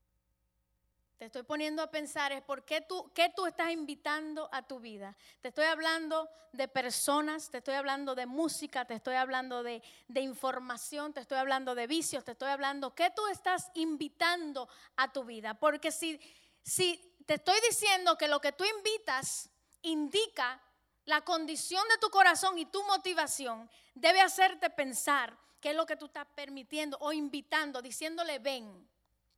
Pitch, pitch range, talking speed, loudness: 295 Hz, 265-330 Hz, 165 wpm, -33 LUFS